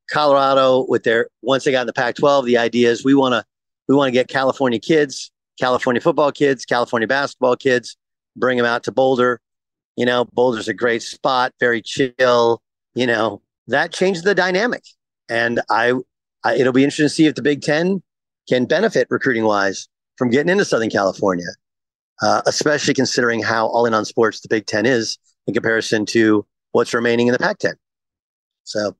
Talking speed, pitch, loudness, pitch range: 185 wpm, 125 Hz, -18 LUFS, 115-140 Hz